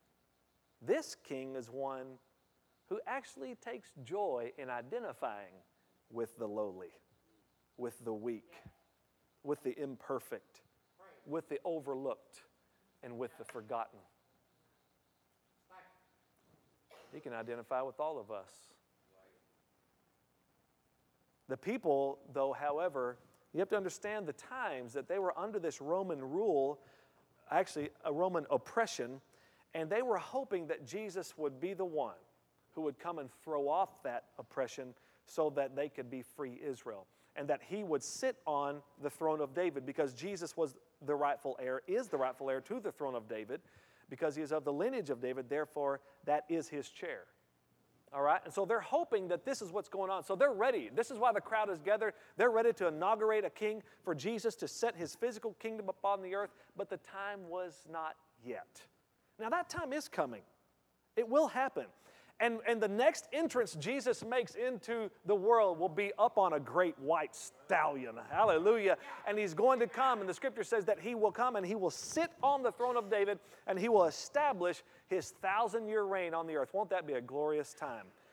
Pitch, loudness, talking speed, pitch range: 170 Hz, -37 LUFS, 175 wpm, 135-215 Hz